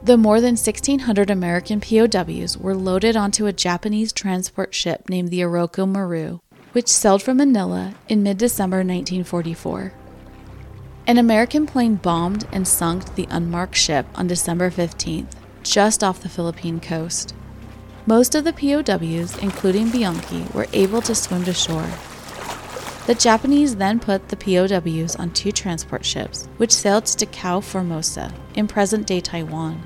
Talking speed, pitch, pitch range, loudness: 145 wpm, 190 Hz, 175-215 Hz, -19 LUFS